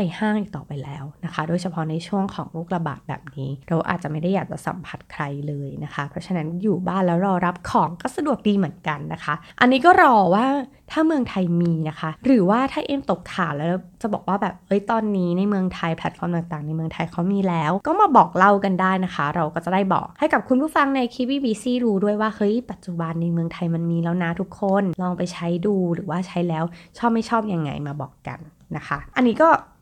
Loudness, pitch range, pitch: -22 LUFS, 165-210 Hz, 180 Hz